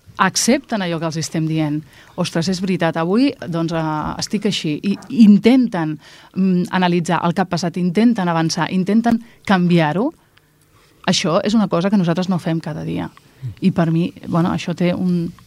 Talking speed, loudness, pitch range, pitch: 160 wpm, -18 LUFS, 165-200 Hz, 175 Hz